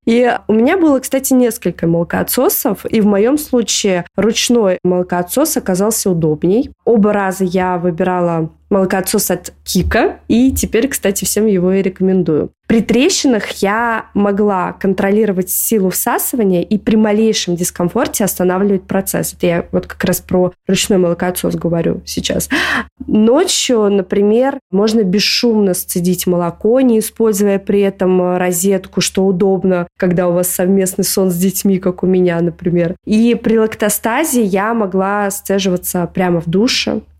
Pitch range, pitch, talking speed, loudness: 180-225 Hz, 195 Hz, 135 wpm, -14 LUFS